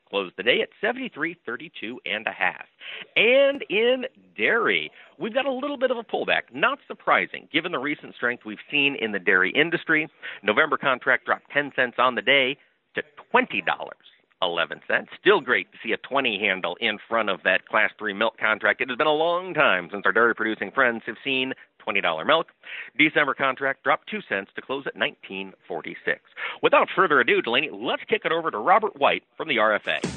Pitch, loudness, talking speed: 150 Hz, -23 LUFS, 190 wpm